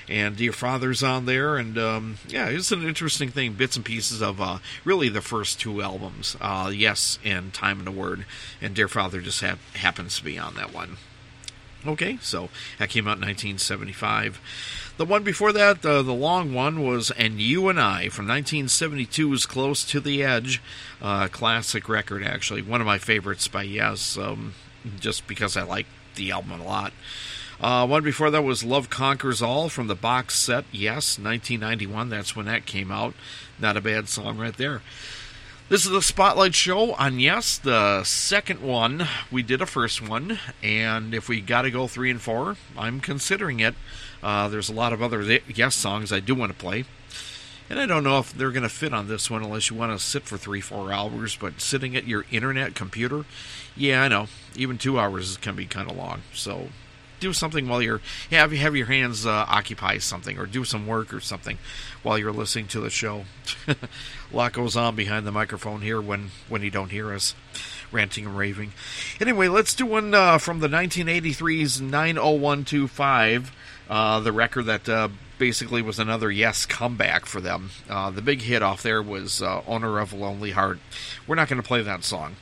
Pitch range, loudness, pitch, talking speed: 105-135 Hz, -24 LUFS, 115 Hz, 195 wpm